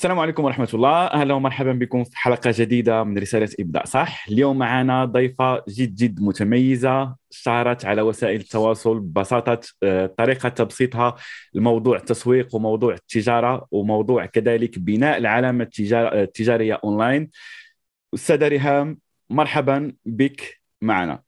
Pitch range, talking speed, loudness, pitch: 110-130 Hz, 120 wpm, -20 LUFS, 120 Hz